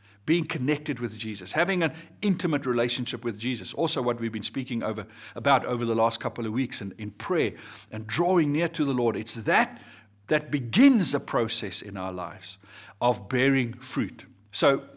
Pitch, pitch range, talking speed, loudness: 120 Hz, 110-145 Hz, 180 wpm, -27 LUFS